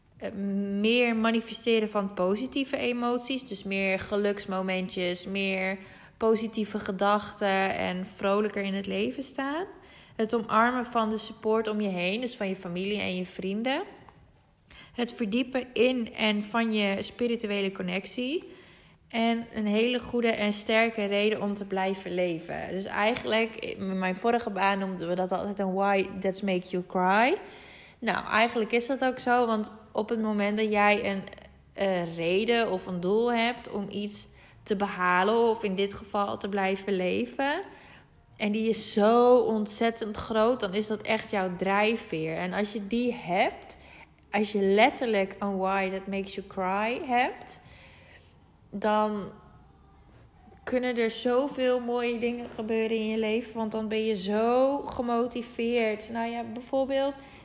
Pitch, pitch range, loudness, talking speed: 215 Hz, 195-235 Hz, -28 LUFS, 150 wpm